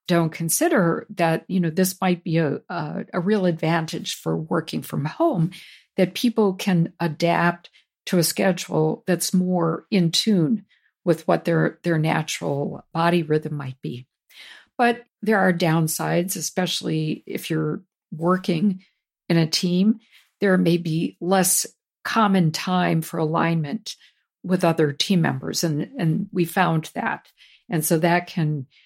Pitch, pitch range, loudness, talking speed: 175 Hz, 165-185 Hz, -22 LUFS, 145 wpm